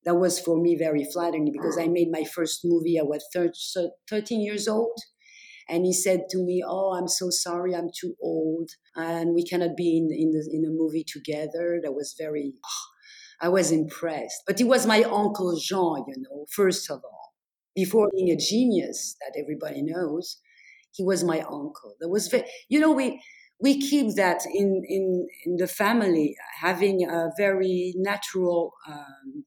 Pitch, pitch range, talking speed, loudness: 175 Hz, 165-200 Hz, 175 wpm, -25 LUFS